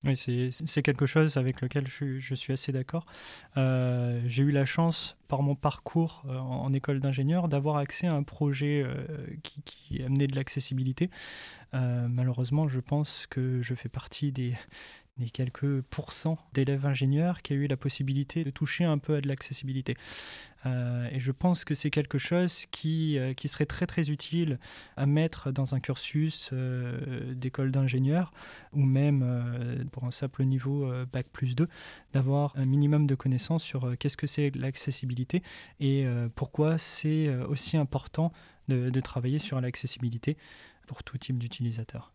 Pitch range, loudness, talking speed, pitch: 130-150 Hz, -30 LUFS, 170 wpm, 135 Hz